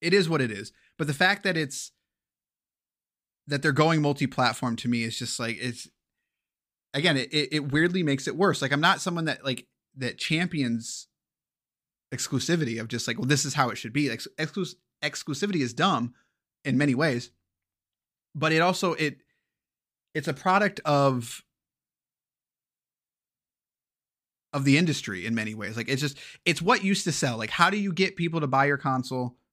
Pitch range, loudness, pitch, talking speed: 120-165 Hz, -26 LUFS, 140 Hz, 175 wpm